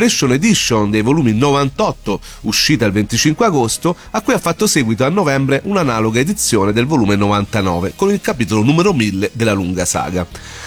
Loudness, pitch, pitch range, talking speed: -15 LUFS, 115 Hz, 105-160 Hz, 160 wpm